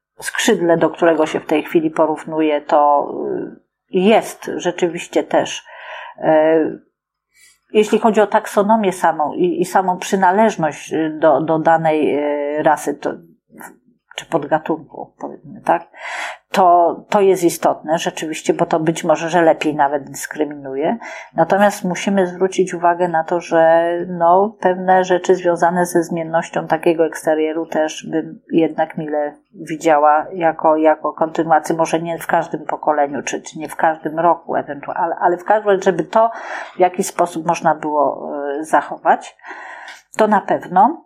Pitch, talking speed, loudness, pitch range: 165 Hz, 135 wpm, -17 LUFS, 155-180 Hz